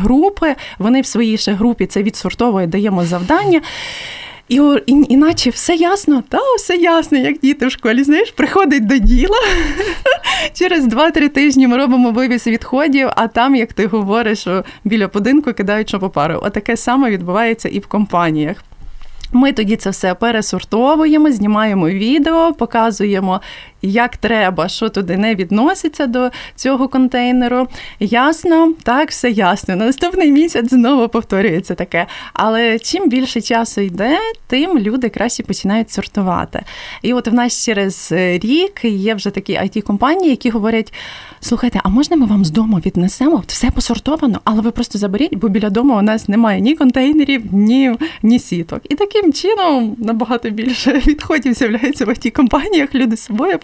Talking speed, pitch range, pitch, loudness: 150 wpm, 210-285 Hz, 240 Hz, -14 LUFS